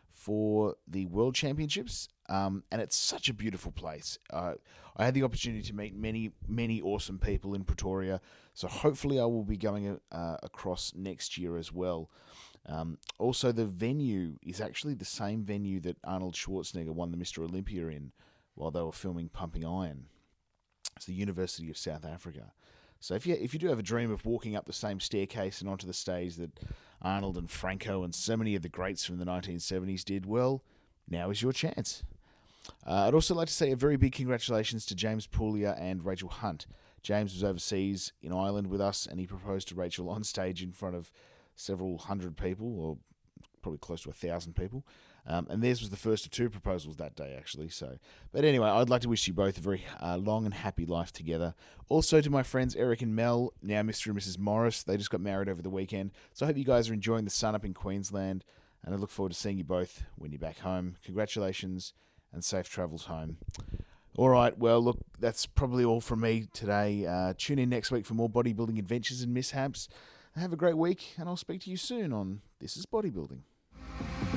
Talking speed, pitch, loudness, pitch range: 210 wpm, 100 Hz, -33 LUFS, 90-115 Hz